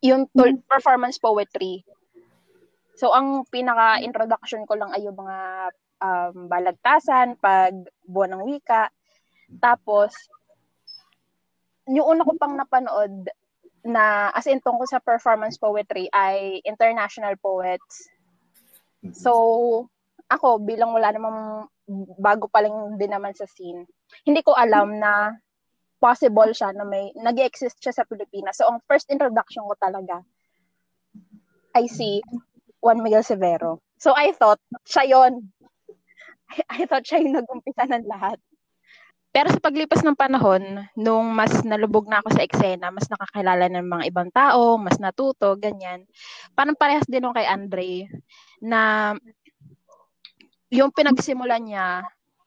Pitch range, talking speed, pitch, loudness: 200-255 Hz, 130 wpm, 220 Hz, -21 LUFS